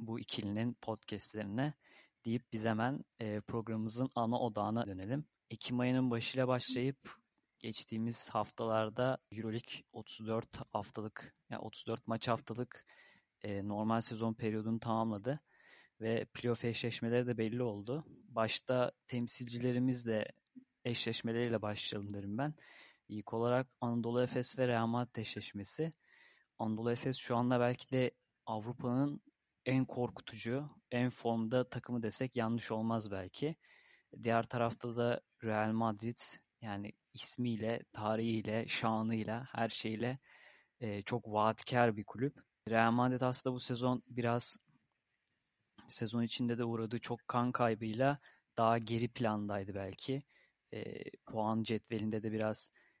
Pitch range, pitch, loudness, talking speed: 110-125 Hz, 115 Hz, -38 LUFS, 110 wpm